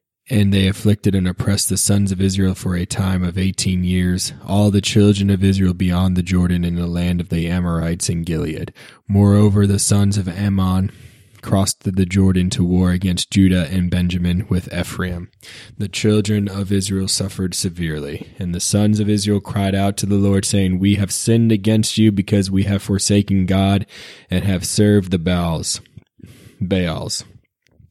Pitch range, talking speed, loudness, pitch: 90-100 Hz, 170 wpm, -18 LUFS, 95 Hz